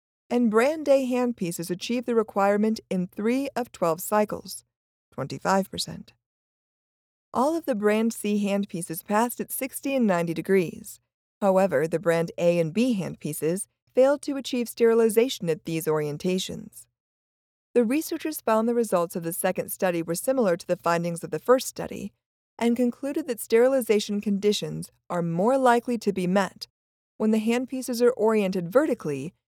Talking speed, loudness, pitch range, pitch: 150 wpm, -25 LUFS, 175-240 Hz, 210 Hz